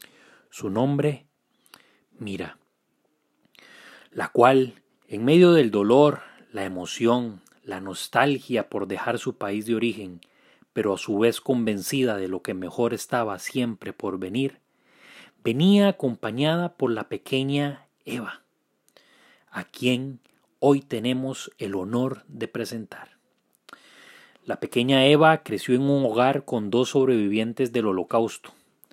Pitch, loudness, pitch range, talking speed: 125 Hz, -24 LUFS, 115-140 Hz, 120 wpm